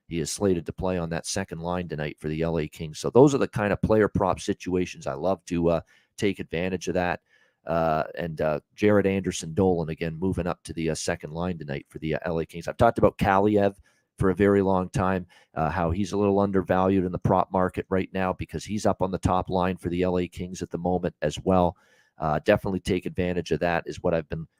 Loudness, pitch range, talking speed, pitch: -26 LUFS, 85-95 Hz, 240 wpm, 90 Hz